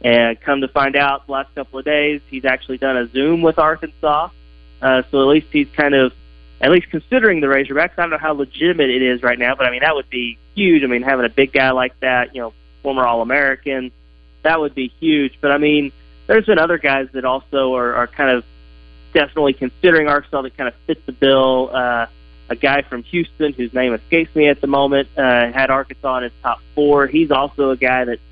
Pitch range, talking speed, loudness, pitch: 125-150 Hz, 230 wpm, -16 LUFS, 135 Hz